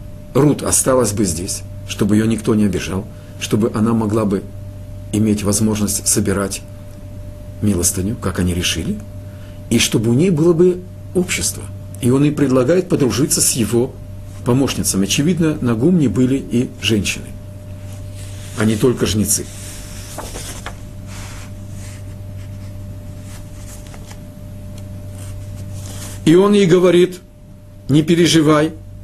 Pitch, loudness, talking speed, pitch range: 100 Hz, -16 LUFS, 105 wpm, 100-115 Hz